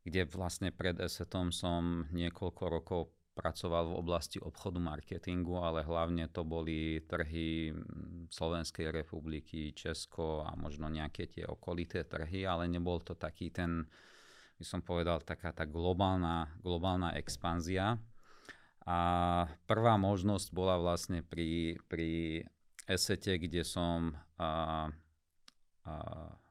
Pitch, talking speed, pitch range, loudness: 85 Hz, 115 wpm, 80-90 Hz, -37 LUFS